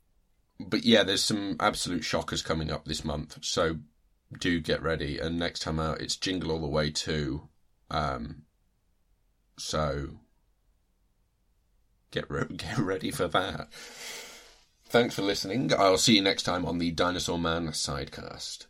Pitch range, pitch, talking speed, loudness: 75-85 Hz, 80 Hz, 145 wpm, -28 LUFS